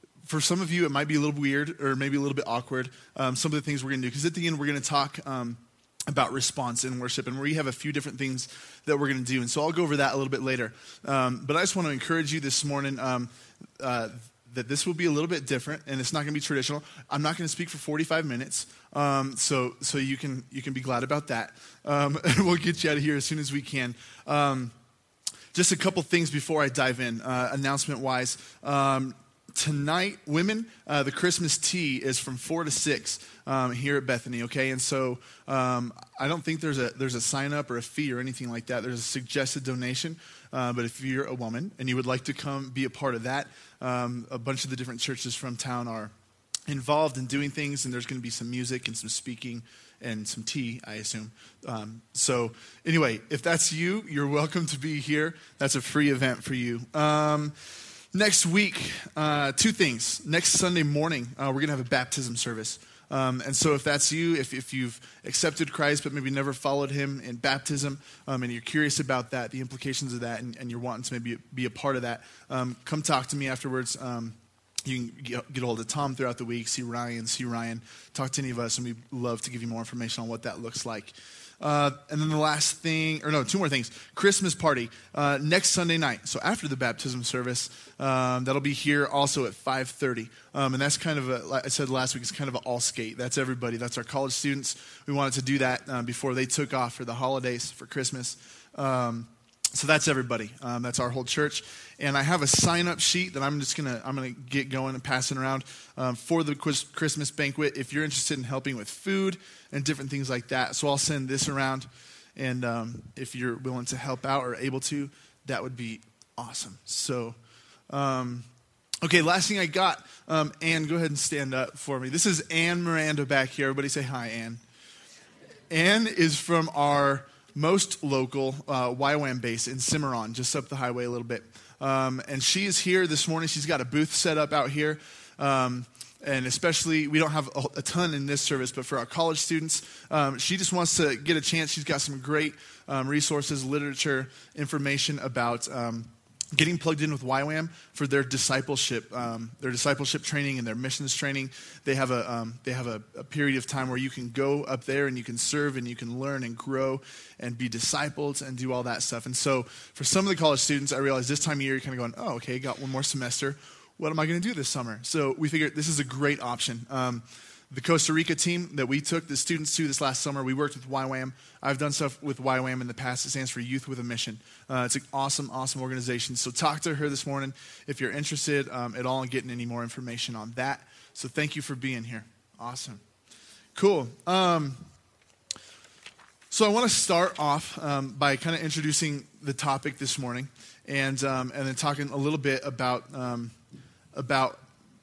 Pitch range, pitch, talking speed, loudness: 125-150 Hz, 135 Hz, 230 wpm, -28 LUFS